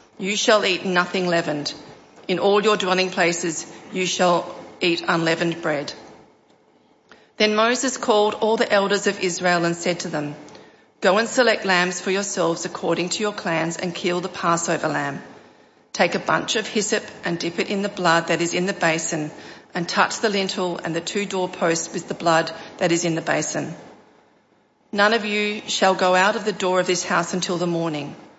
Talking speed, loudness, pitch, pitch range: 190 wpm, -21 LUFS, 180 Hz, 170-205 Hz